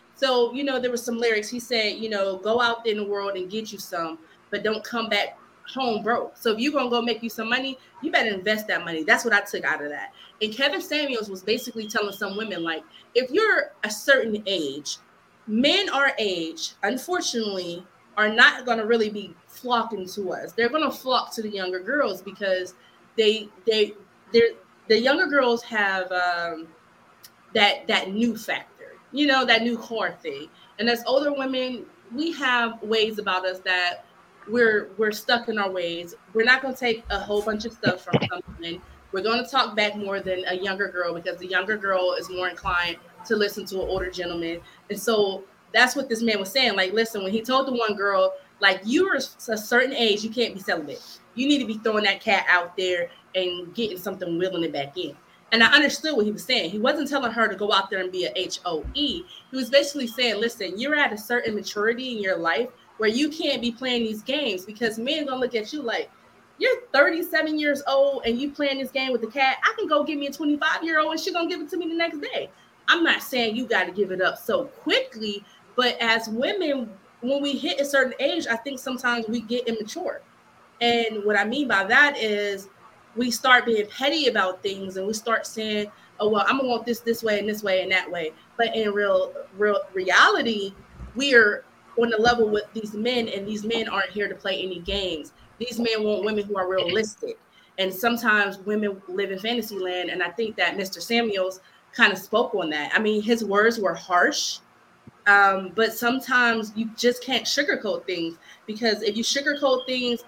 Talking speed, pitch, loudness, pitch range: 215 wpm, 225 Hz, -23 LUFS, 195-255 Hz